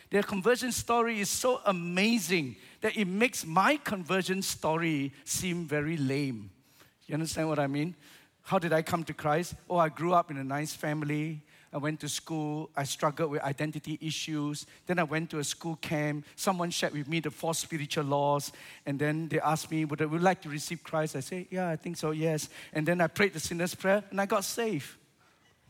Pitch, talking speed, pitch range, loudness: 160 Hz, 205 wpm, 150-180 Hz, -31 LUFS